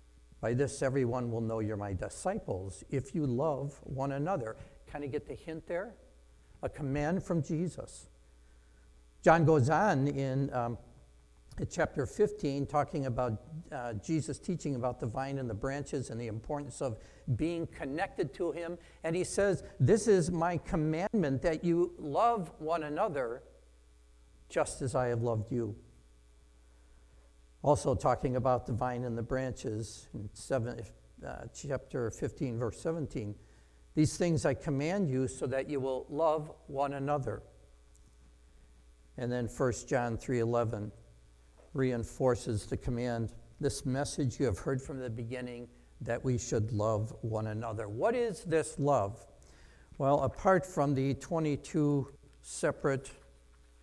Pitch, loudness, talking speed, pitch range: 130 Hz, -34 LUFS, 140 wpm, 105-145 Hz